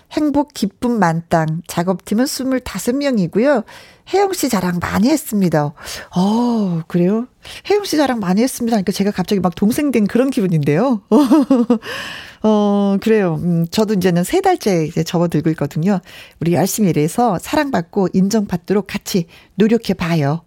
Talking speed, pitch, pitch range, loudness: 310 characters per minute, 205 Hz, 175-240 Hz, -17 LUFS